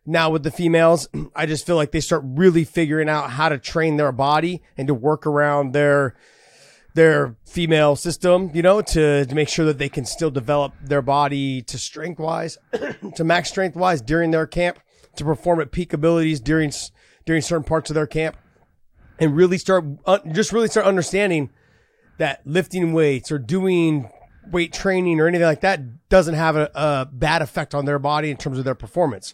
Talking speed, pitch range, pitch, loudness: 190 wpm, 145-170 Hz, 160 Hz, -20 LUFS